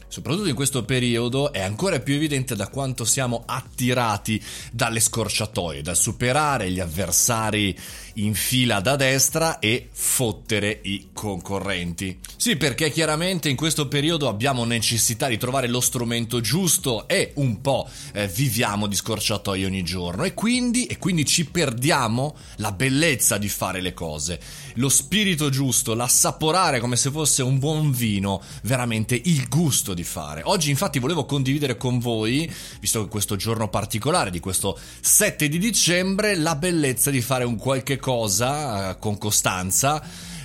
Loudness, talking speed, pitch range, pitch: -22 LUFS, 150 wpm, 105-145 Hz, 125 Hz